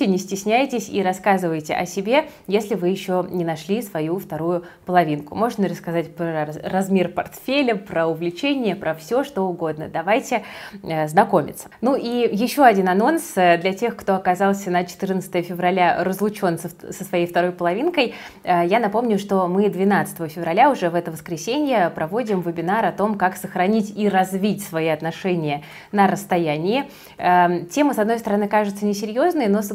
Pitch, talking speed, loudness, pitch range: 190 Hz, 150 wpm, -21 LUFS, 175-215 Hz